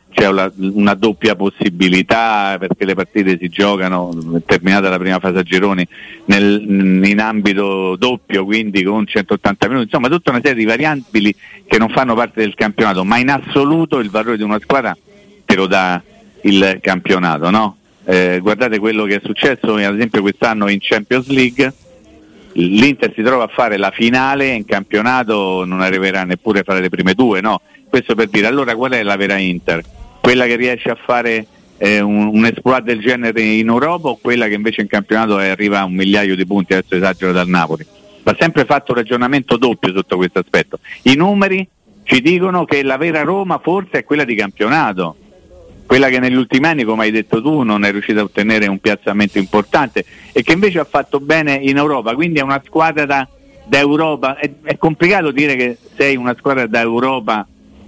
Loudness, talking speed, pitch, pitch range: -14 LUFS, 185 wpm, 110 Hz, 100-130 Hz